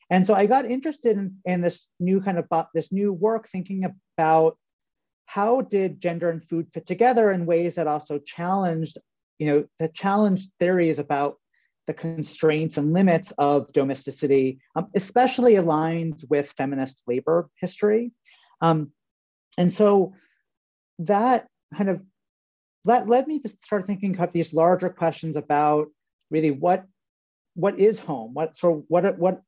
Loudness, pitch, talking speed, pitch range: -23 LUFS, 175 Hz, 150 wpm, 155-200 Hz